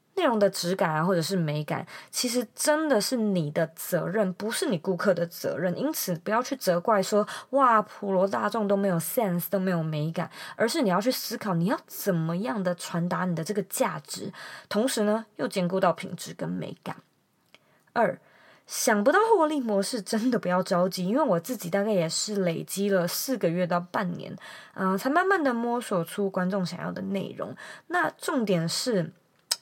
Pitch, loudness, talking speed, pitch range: 195 Hz, -27 LUFS, 280 characters per minute, 180-230 Hz